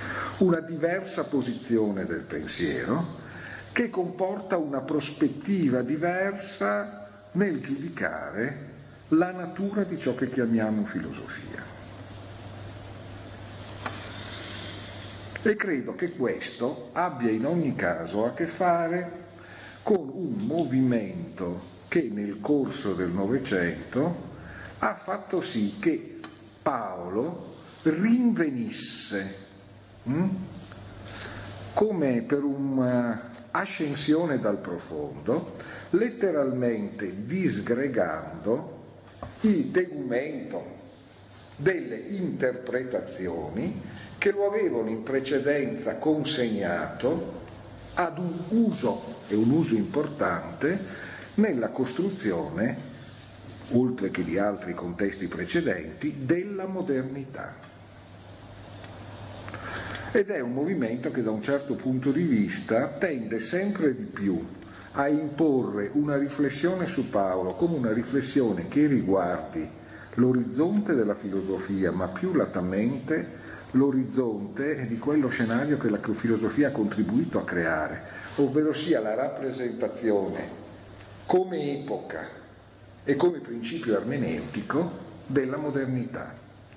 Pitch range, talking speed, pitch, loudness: 100-150 Hz, 90 wpm, 125 Hz, -28 LUFS